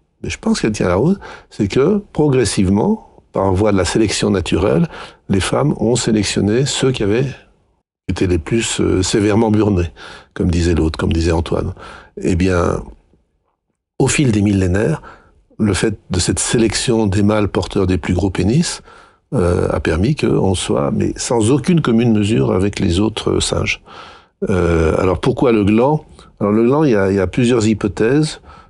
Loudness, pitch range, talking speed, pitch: -16 LUFS, 95-120 Hz, 170 wpm, 105 Hz